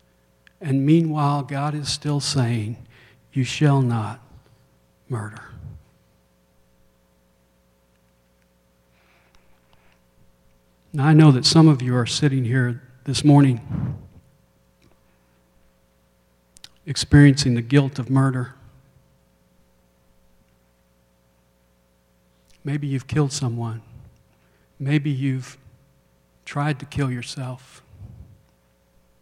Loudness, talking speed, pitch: -20 LUFS, 75 wpm, 105 Hz